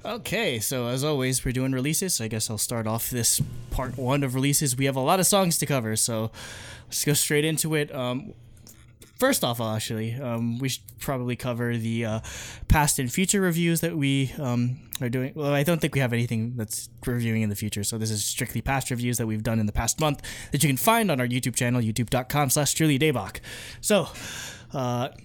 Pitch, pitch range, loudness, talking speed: 125 Hz, 115-140 Hz, -25 LUFS, 215 wpm